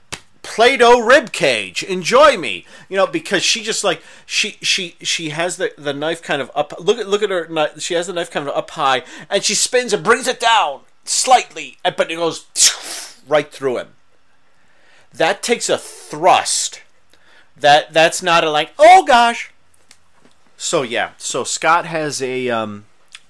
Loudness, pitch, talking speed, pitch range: -16 LUFS, 185 Hz, 175 wpm, 160-230 Hz